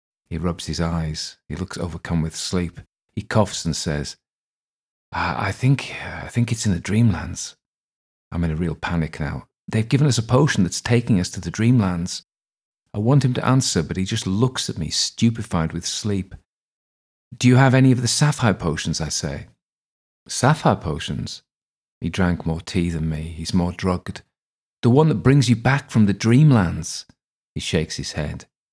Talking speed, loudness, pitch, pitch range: 180 wpm, -21 LUFS, 95 Hz, 85-120 Hz